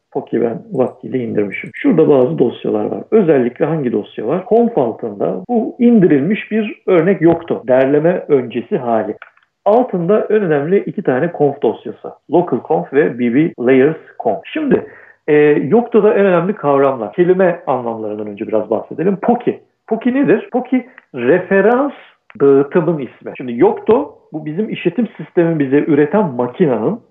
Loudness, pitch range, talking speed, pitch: -15 LUFS, 140-220 Hz, 140 wpm, 180 Hz